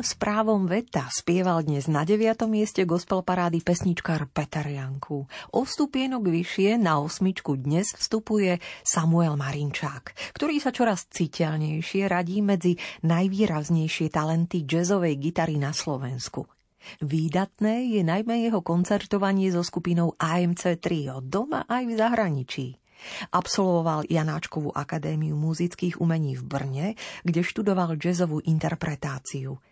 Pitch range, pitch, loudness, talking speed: 155-200 Hz, 170 Hz, -26 LUFS, 115 wpm